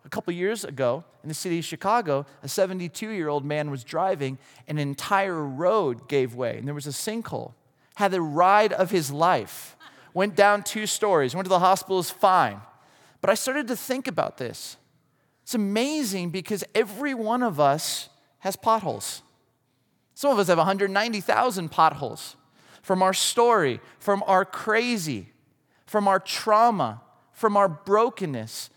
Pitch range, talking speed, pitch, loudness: 150-215 Hz, 160 wpm, 190 Hz, -24 LUFS